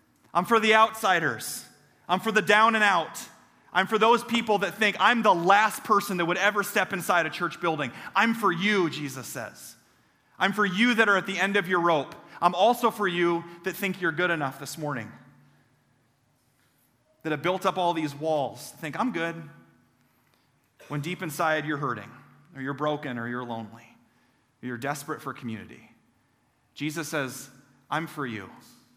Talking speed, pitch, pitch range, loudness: 180 wpm, 165 Hz, 140-195 Hz, -25 LUFS